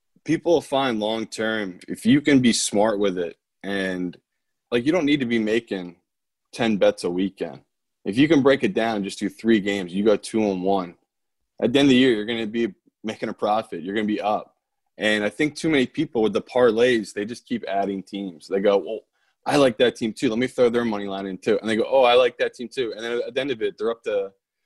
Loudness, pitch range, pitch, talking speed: -22 LUFS, 100-135 Hz, 115 Hz, 260 wpm